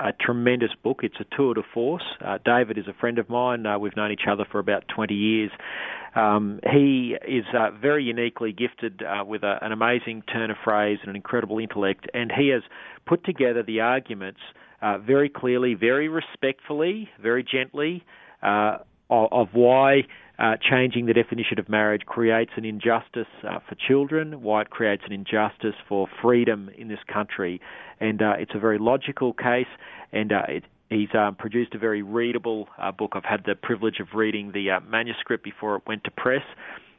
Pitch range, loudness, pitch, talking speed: 105-125 Hz, -24 LUFS, 115 Hz, 185 wpm